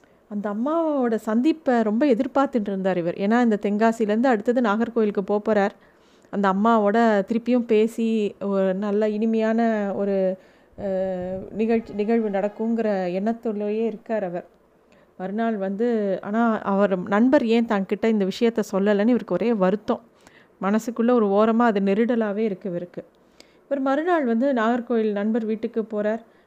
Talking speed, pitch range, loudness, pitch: 120 wpm, 200-230 Hz, -22 LUFS, 220 Hz